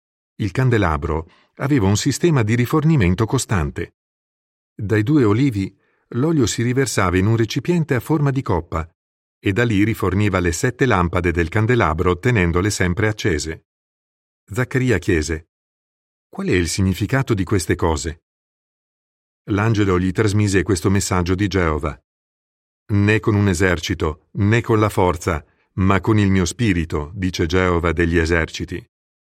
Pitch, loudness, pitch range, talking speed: 100 Hz, -19 LUFS, 90-115 Hz, 135 wpm